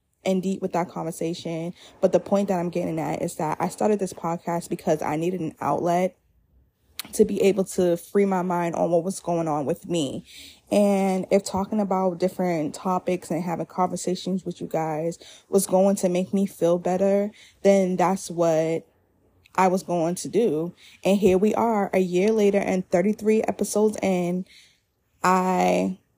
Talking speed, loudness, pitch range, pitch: 175 wpm, -24 LUFS, 170-195 Hz, 180 Hz